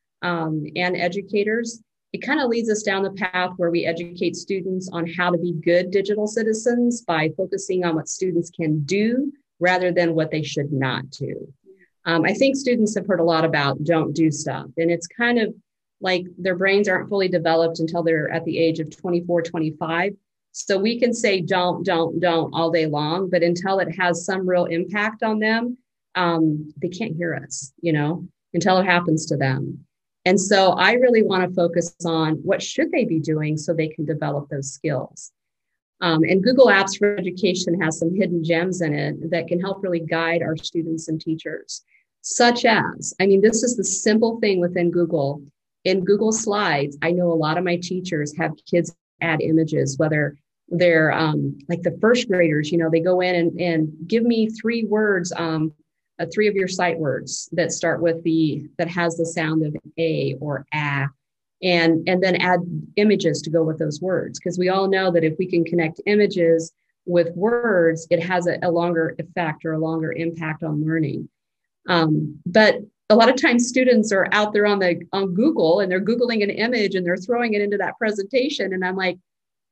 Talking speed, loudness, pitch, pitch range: 200 wpm, -21 LUFS, 175 Hz, 165-195 Hz